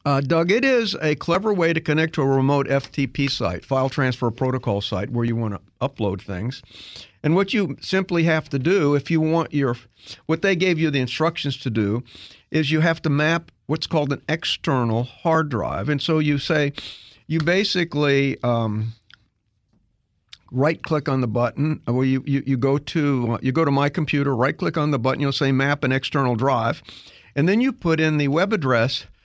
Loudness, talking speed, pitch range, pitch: -21 LUFS, 195 wpm, 120-160 Hz, 140 Hz